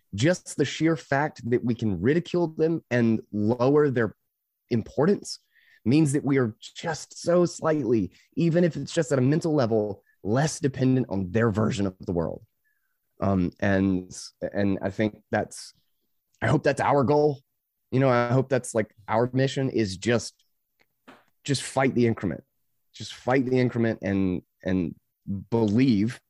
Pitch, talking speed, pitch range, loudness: 120 Hz, 155 wpm, 105-140 Hz, -25 LUFS